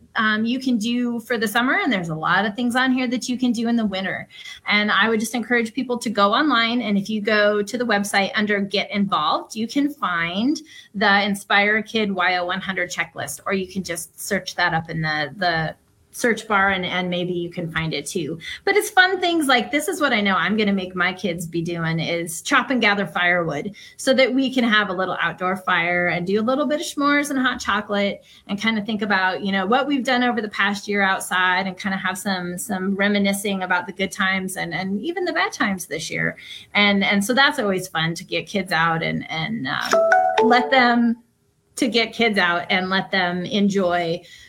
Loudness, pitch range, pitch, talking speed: -20 LUFS, 185-245 Hz, 205 Hz, 225 wpm